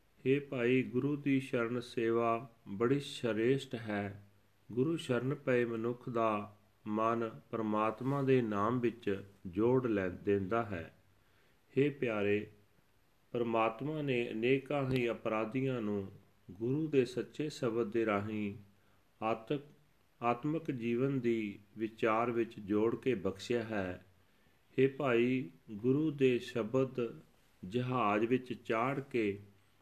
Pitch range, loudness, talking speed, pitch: 105-130 Hz, -35 LUFS, 110 wpm, 115 Hz